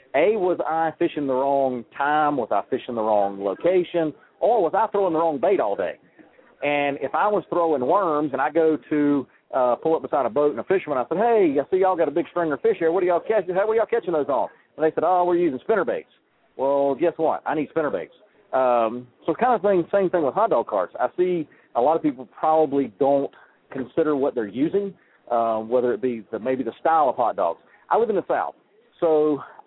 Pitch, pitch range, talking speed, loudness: 155 Hz, 135-180 Hz, 240 wpm, -22 LUFS